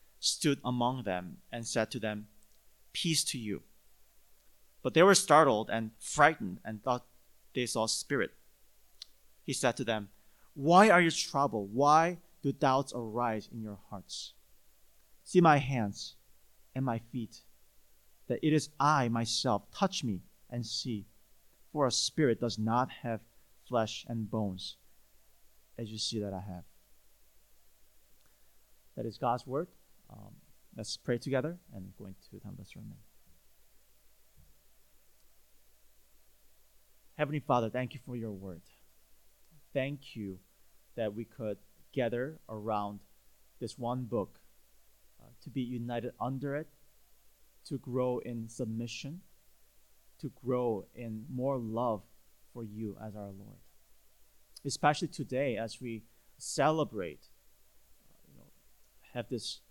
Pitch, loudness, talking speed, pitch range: 120 Hz, -32 LUFS, 130 wpm, 110-135 Hz